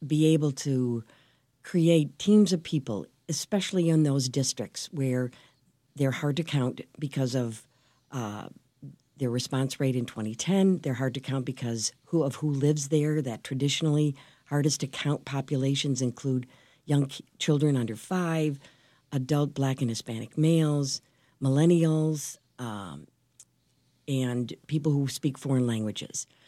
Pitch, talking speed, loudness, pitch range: 140 Hz, 130 wpm, -28 LUFS, 125-150 Hz